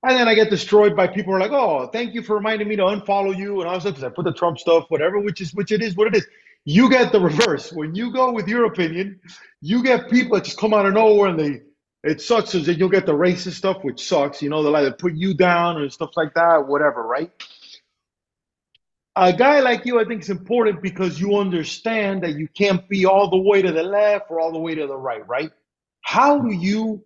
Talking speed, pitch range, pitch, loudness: 255 wpm, 170-215 Hz, 195 Hz, -19 LUFS